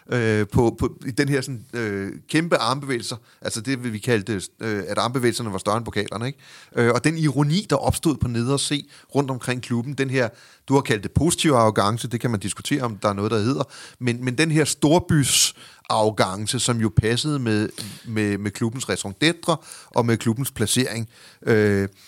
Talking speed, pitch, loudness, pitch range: 180 wpm, 120 Hz, -22 LUFS, 110-140 Hz